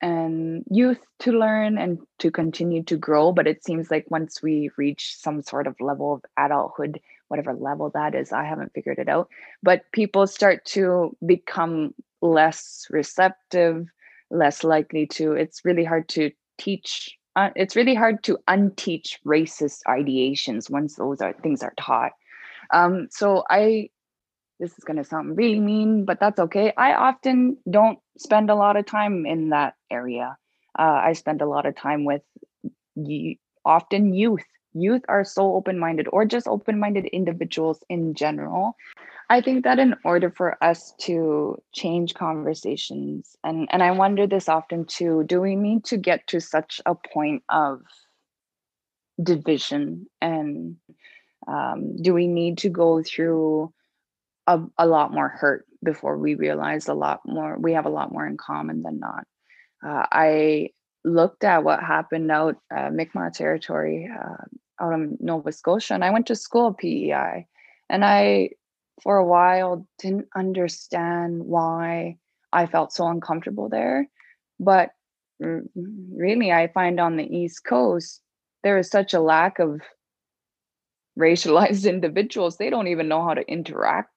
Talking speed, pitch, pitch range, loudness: 155 wpm, 170 Hz, 155-195 Hz, -22 LUFS